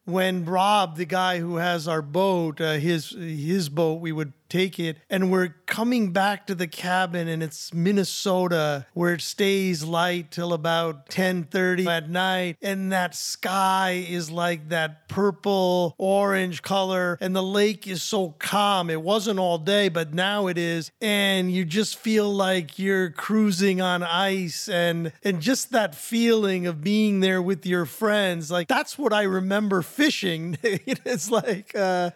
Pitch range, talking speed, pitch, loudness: 170-200 Hz, 165 wpm, 185 Hz, -24 LUFS